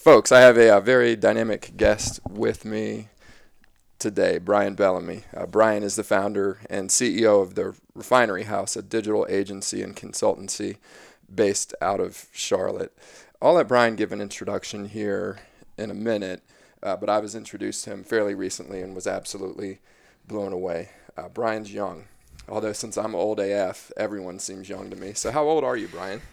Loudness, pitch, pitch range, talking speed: -23 LUFS, 105 Hz, 100-115 Hz, 175 wpm